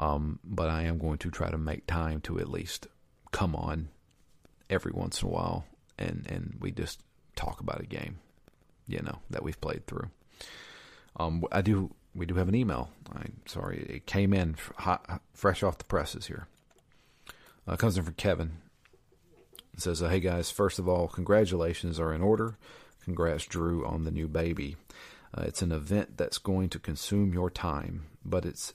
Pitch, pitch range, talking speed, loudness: 85 Hz, 80-95 Hz, 190 wpm, -32 LUFS